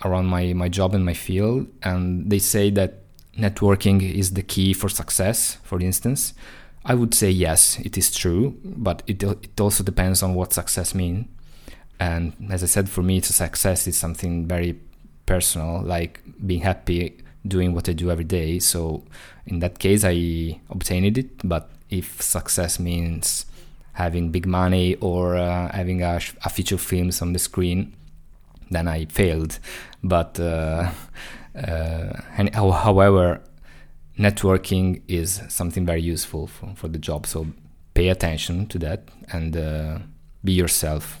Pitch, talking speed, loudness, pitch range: 90 Hz, 155 wpm, -22 LUFS, 85-95 Hz